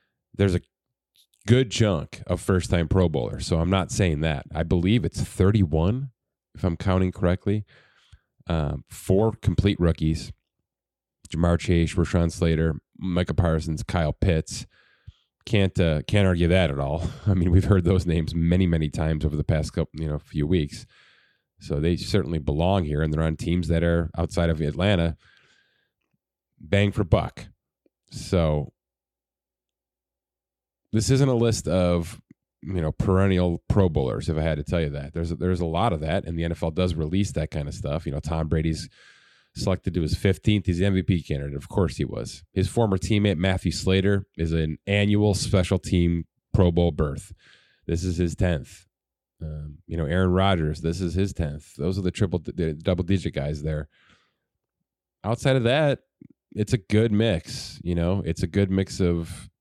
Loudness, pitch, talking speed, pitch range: -24 LUFS, 90 Hz, 175 wpm, 80-95 Hz